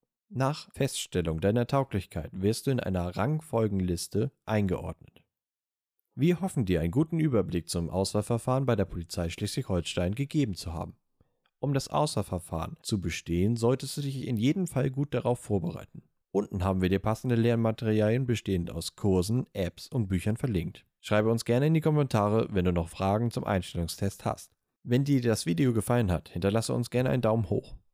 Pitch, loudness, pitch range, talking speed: 110 Hz, -29 LUFS, 90-130 Hz, 165 wpm